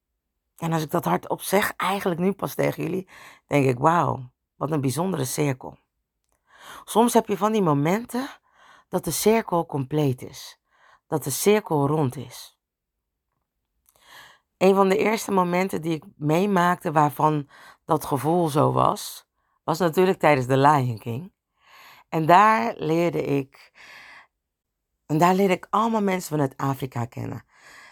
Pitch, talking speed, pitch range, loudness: 165 Hz, 140 wpm, 140-195 Hz, -23 LUFS